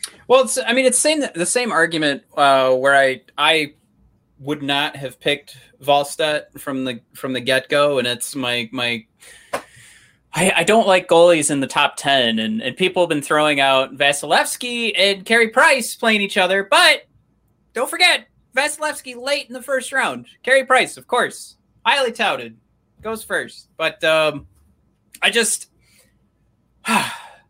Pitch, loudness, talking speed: 160 Hz, -17 LUFS, 155 wpm